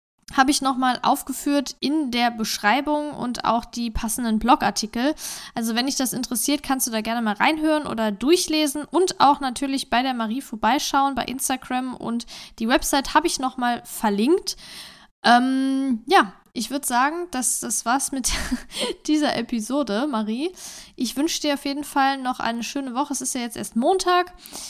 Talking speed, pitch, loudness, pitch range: 170 wpm, 265 Hz, -22 LUFS, 235-290 Hz